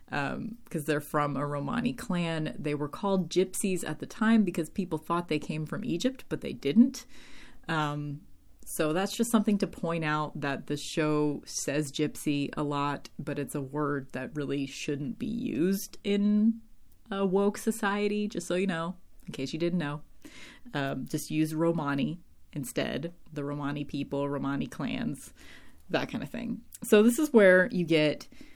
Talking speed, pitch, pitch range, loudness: 170 wpm, 165 Hz, 145-205 Hz, -30 LUFS